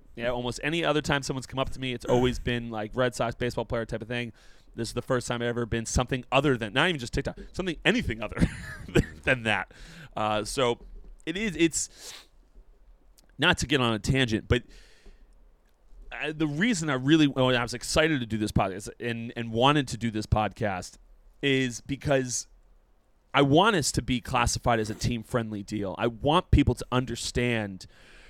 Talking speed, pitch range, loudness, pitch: 195 wpm, 115-135 Hz, -27 LUFS, 120 Hz